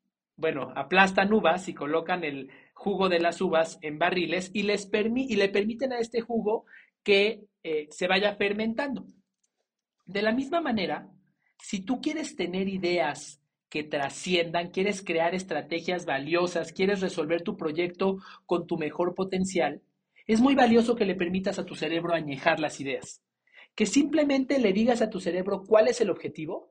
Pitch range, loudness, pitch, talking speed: 170-220 Hz, -27 LUFS, 190 Hz, 160 wpm